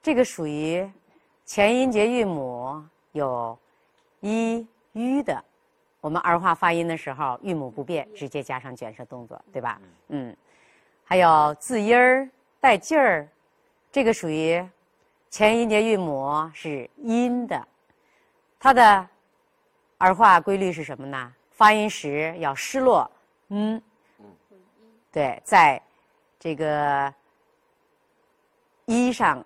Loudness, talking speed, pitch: -22 LUFS, 165 characters per minute, 215 Hz